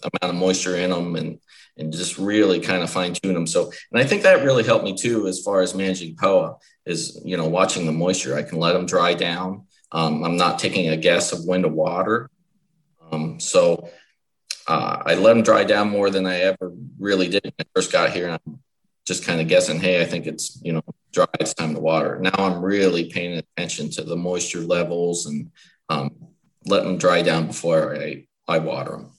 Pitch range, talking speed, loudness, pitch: 85-95 Hz, 215 wpm, -21 LUFS, 90 Hz